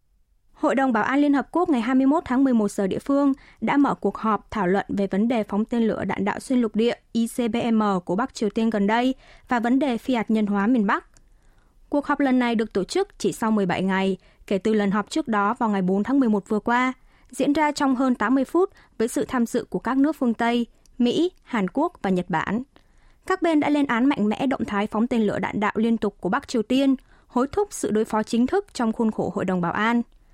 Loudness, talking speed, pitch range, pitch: -23 LUFS, 250 wpm, 210-265 Hz, 235 Hz